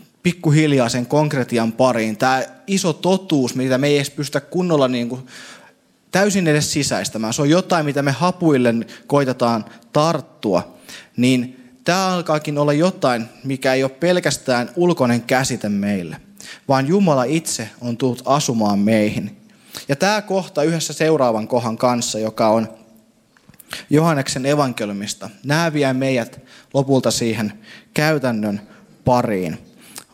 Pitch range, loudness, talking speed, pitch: 120-155 Hz, -18 LUFS, 125 wpm, 130 Hz